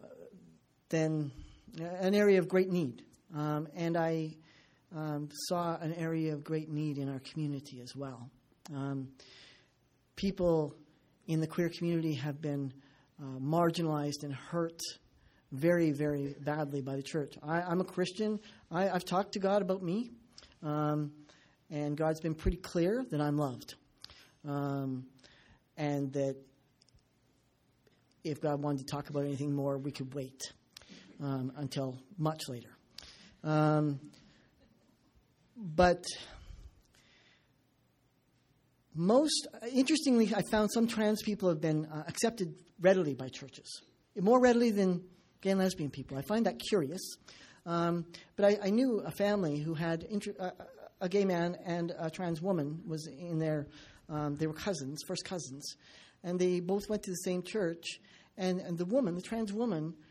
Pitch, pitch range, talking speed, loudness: 160 Hz, 145-185 Hz, 145 wpm, -34 LUFS